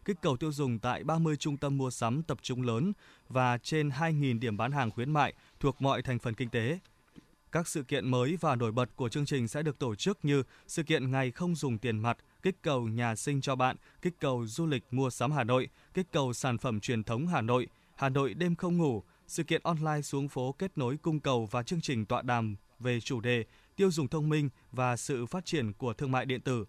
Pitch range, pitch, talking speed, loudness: 120-155 Hz, 135 Hz, 240 wpm, -32 LUFS